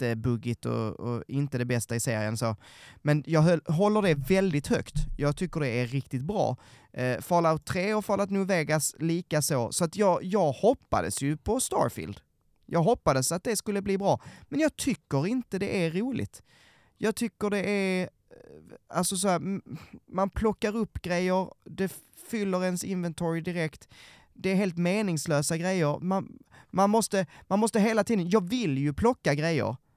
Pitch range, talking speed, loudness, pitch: 140-200 Hz, 170 wpm, -28 LUFS, 175 Hz